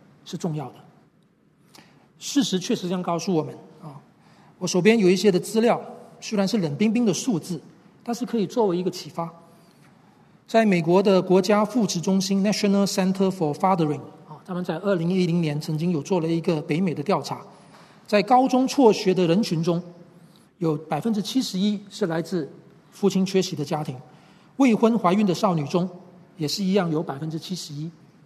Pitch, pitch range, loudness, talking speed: 185 Hz, 165-205 Hz, -23 LUFS, 310 characters per minute